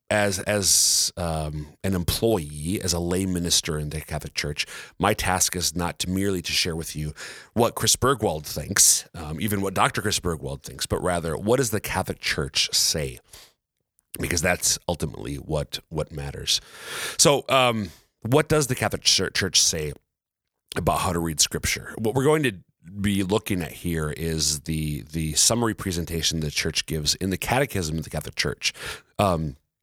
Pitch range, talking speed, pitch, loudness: 75-100 Hz, 175 wpm, 85 Hz, -23 LUFS